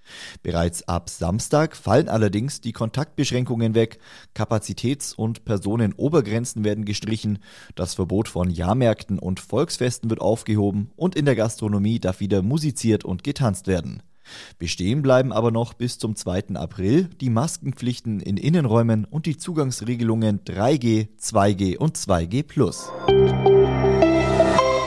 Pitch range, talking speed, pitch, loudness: 100-125 Hz, 120 wpm, 110 Hz, -22 LUFS